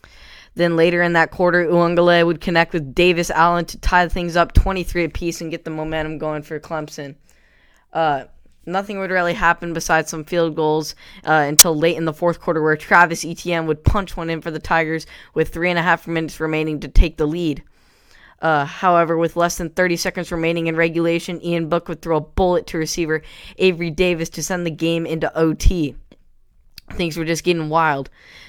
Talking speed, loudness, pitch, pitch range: 195 wpm, -18 LUFS, 165 Hz, 160-175 Hz